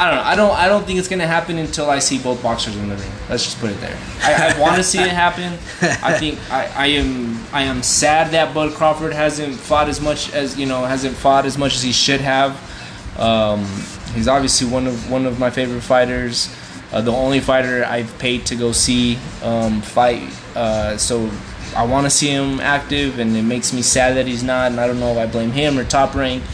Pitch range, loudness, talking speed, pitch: 120-145 Hz, -17 LUFS, 235 wpm, 130 Hz